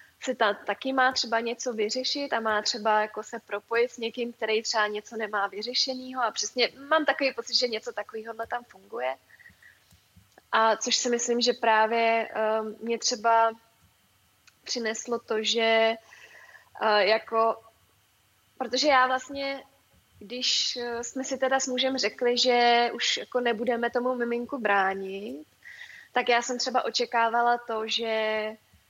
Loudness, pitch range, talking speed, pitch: -26 LUFS, 220-250 Hz, 135 wpm, 230 Hz